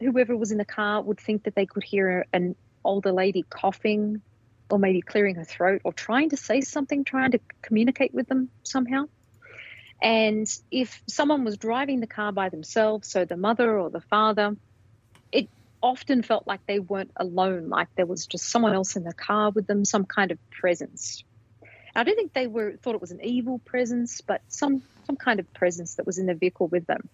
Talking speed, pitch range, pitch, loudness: 205 wpm, 185-245 Hz, 210 Hz, -26 LUFS